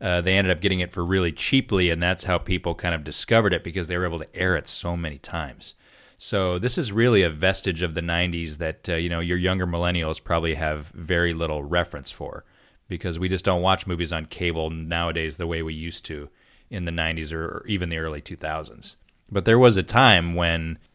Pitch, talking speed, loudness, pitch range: 85 Hz, 220 wpm, -23 LUFS, 80-95 Hz